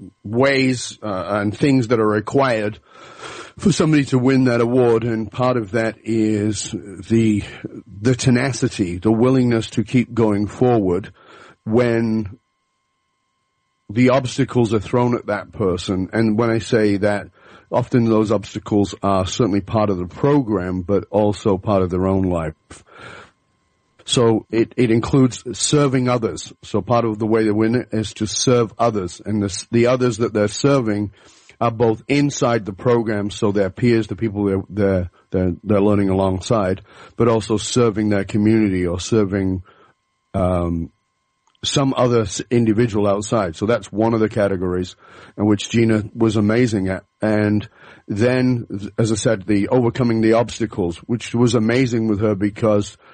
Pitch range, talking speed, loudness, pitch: 100-120 Hz, 155 wpm, -19 LUFS, 110 Hz